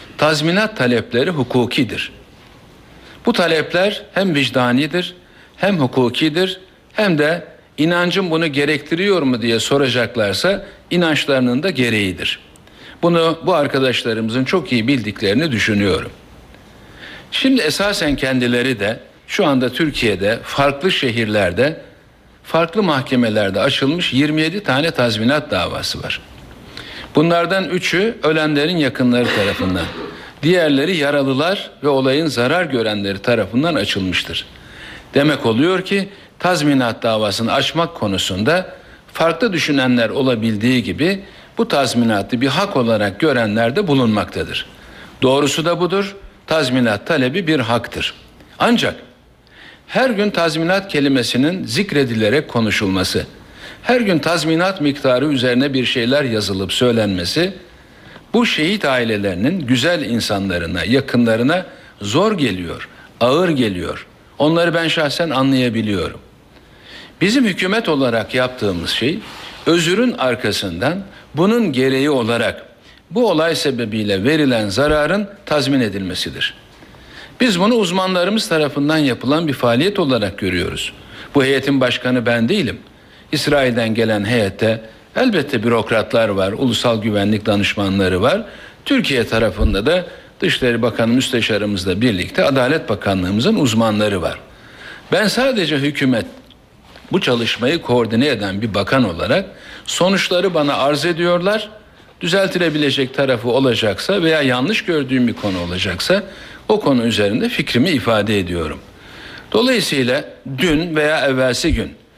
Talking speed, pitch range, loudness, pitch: 105 wpm, 115-170 Hz, -16 LUFS, 135 Hz